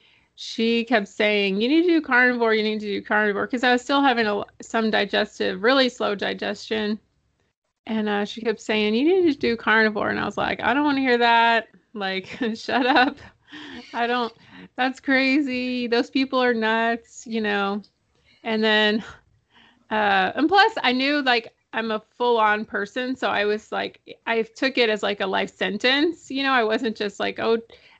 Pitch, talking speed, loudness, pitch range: 230 Hz, 190 wpm, -22 LUFS, 215-255 Hz